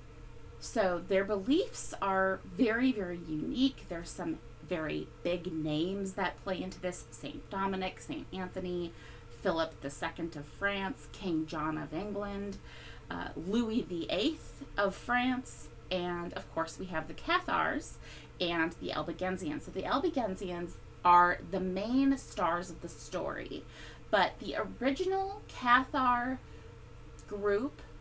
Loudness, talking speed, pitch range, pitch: -33 LUFS, 125 wpm, 165-215 Hz, 185 Hz